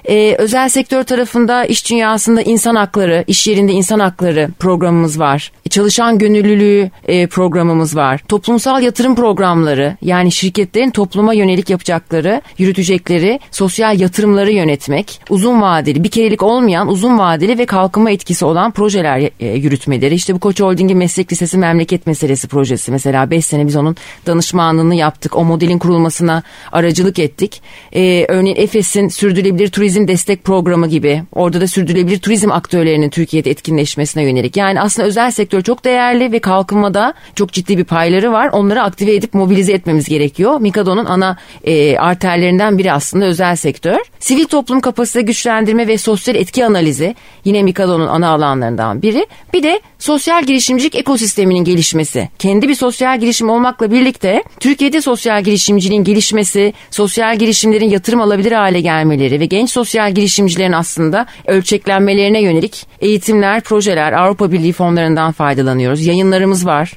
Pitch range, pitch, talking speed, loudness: 170-215 Hz, 195 Hz, 145 wpm, -12 LUFS